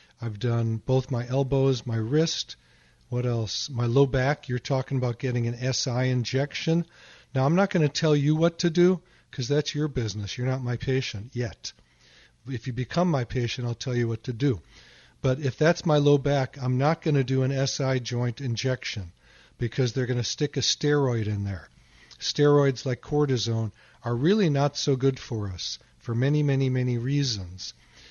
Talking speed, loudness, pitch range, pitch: 190 wpm, -26 LUFS, 120-145 Hz, 130 Hz